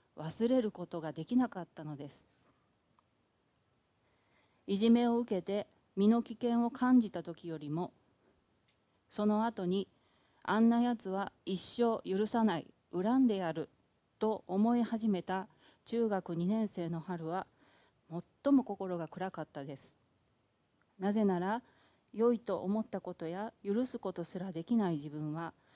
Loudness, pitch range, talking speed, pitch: -34 LUFS, 170-230 Hz, 245 characters per minute, 195 Hz